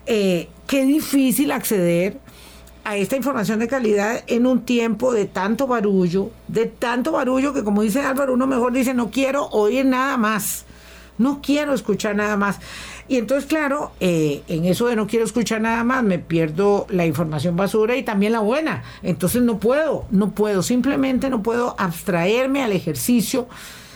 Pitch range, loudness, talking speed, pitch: 190-255 Hz, -20 LUFS, 170 wpm, 225 Hz